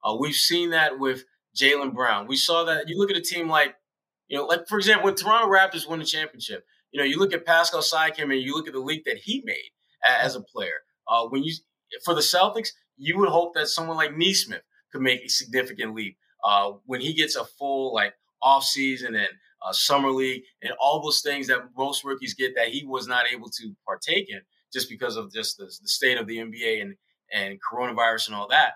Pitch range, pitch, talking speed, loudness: 130-170 Hz, 145 Hz, 225 wpm, -24 LUFS